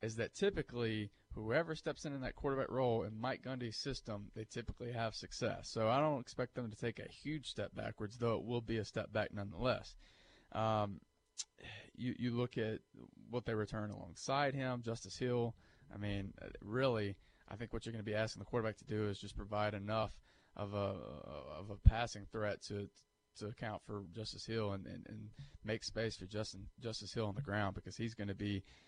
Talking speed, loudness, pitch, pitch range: 200 wpm, -41 LUFS, 110 Hz, 105-120 Hz